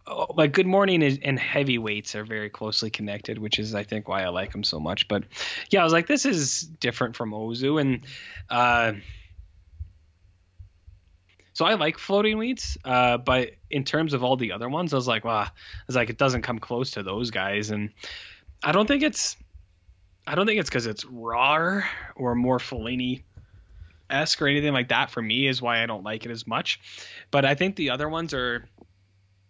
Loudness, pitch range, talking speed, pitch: -25 LUFS, 100-140 Hz, 200 wpm, 120 Hz